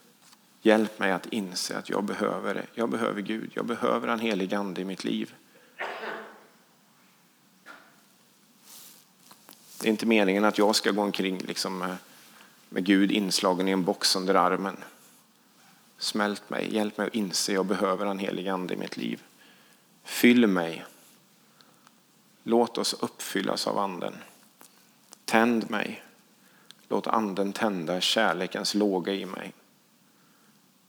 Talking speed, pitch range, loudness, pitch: 130 wpm, 95-110 Hz, -27 LUFS, 100 Hz